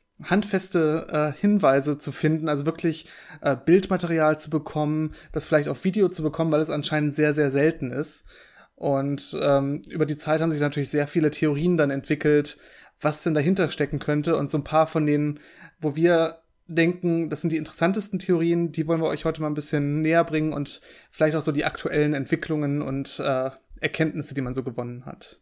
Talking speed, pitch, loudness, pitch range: 190 wpm, 155 Hz, -24 LUFS, 150-165 Hz